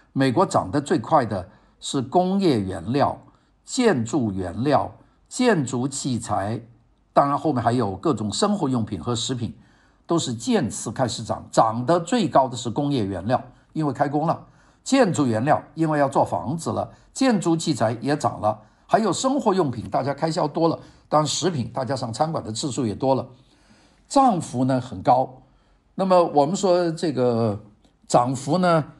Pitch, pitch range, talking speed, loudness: 140 Hz, 120-165 Hz, 240 characters per minute, -22 LUFS